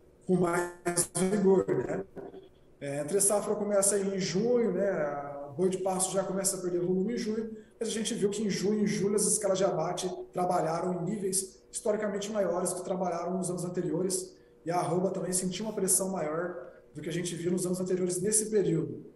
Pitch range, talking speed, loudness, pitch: 175-200 Hz, 205 wpm, -30 LUFS, 185 Hz